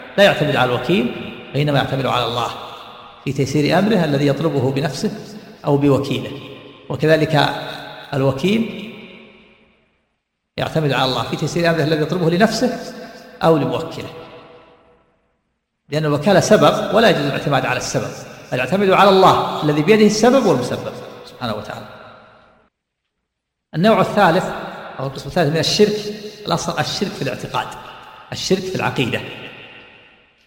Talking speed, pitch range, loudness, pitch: 120 wpm, 135-200 Hz, -17 LUFS, 160 Hz